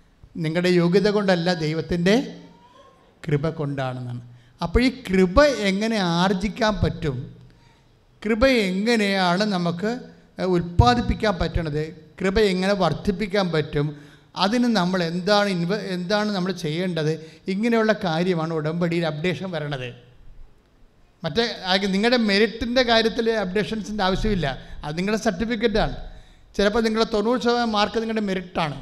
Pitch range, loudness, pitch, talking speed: 155-215 Hz, -22 LUFS, 185 Hz, 100 wpm